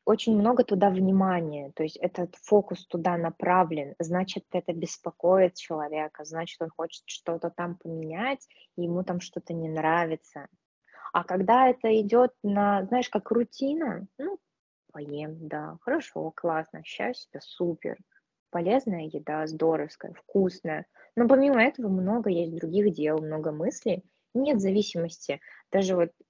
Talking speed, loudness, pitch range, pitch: 130 wpm, -27 LUFS, 165-215 Hz, 180 Hz